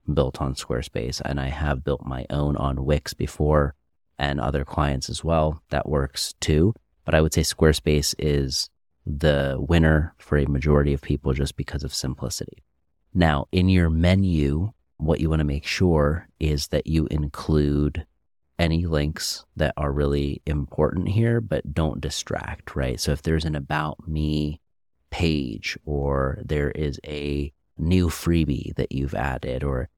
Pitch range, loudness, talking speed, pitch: 70-80 Hz, -24 LUFS, 160 wpm, 75 Hz